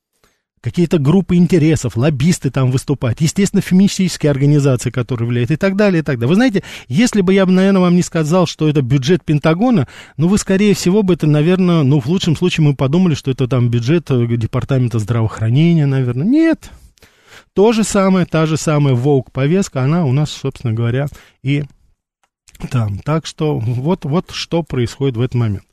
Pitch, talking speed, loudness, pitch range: 155 Hz, 175 wpm, -15 LUFS, 130-180 Hz